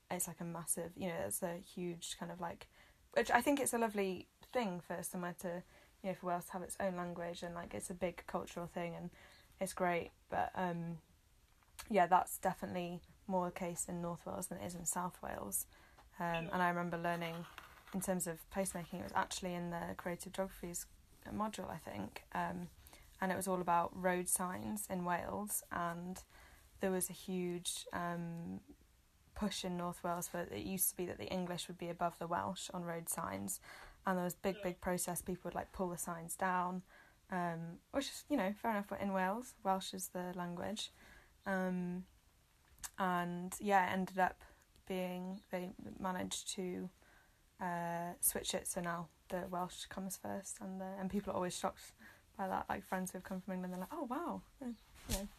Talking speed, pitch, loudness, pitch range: 195 wpm, 180 Hz, -41 LUFS, 175-190 Hz